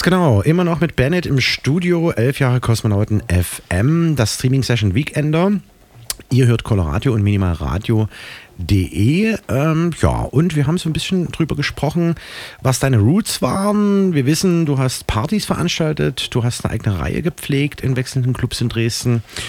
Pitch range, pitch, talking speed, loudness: 110-165 Hz, 130 Hz, 155 wpm, -17 LUFS